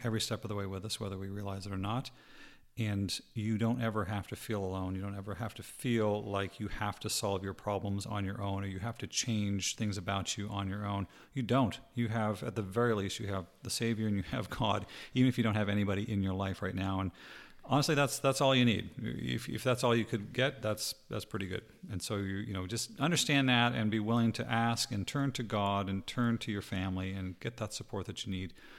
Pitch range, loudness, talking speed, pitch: 100-115 Hz, -34 LUFS, 255 wpm, 105 Hz